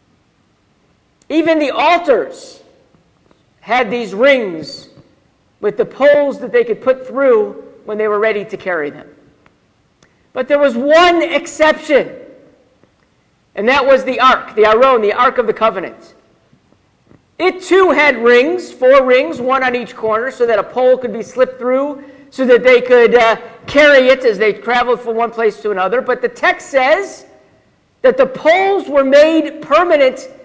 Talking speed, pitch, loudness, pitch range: 160 wpm, 265 Hz, -12 LUFS, 240-310 Hz